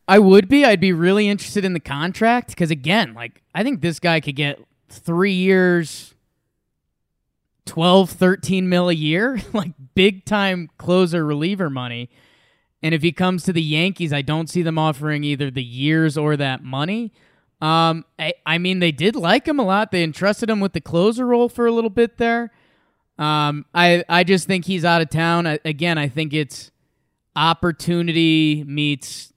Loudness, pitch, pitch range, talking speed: -18 LUFS, 170 Hz, 150-190 Hz, 180 wpm